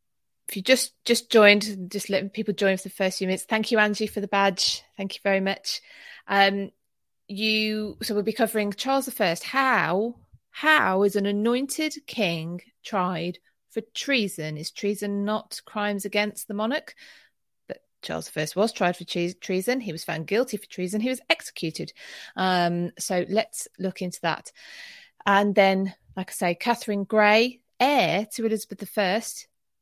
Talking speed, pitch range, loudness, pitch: 165 wpm, 190-225 Hz, -25 LUFS, 205 Hz